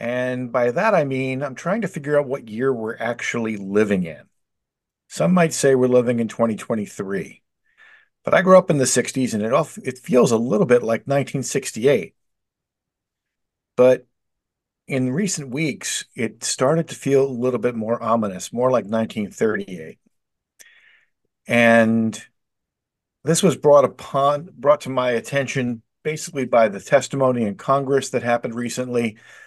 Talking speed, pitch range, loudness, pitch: 150 wpm, 115-145 Hz, -20 LUFS, 125 Hz